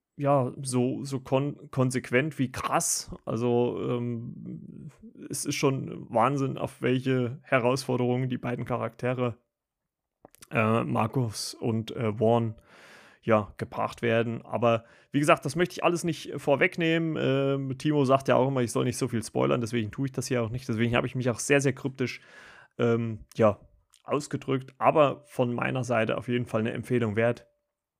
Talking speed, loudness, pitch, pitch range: 165 wpm, -28 LUFS, 125 Hz, 120-140 Hz